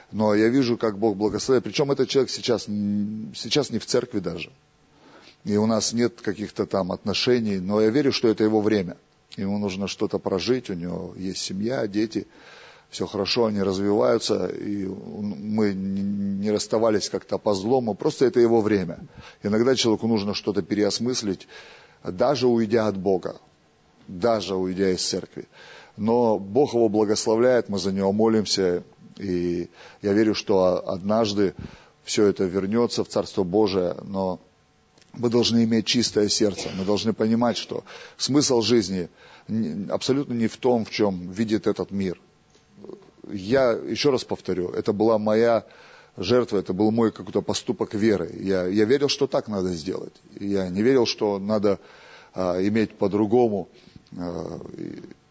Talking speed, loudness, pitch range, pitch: 150 wpm, -23 LUFS, 95-115 Hz, 105 Hz